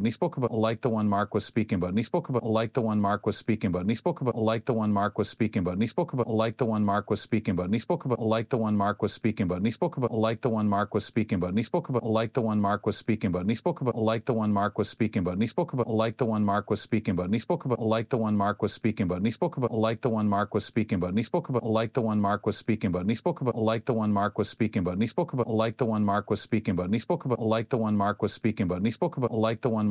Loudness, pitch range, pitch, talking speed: -28 LUFS, 105-120 Hz, 110 Hz, 335 wpm